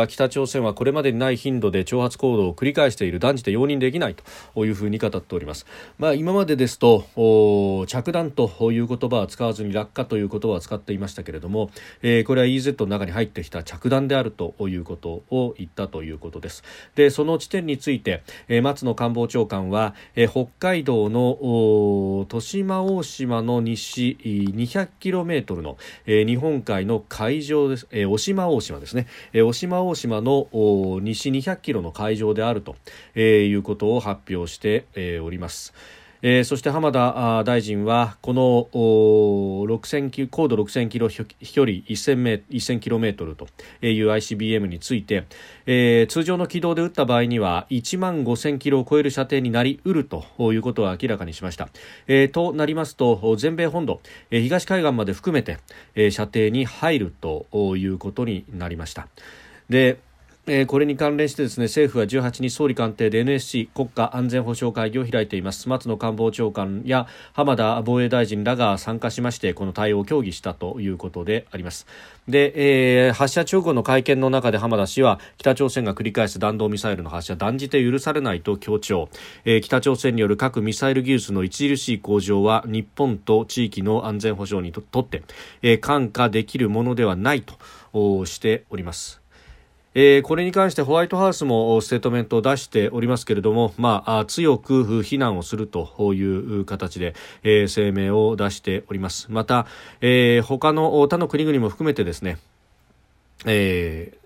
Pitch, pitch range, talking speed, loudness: 115 Hz, 105-135 Hz, 325 characters per minute, -21 LUFS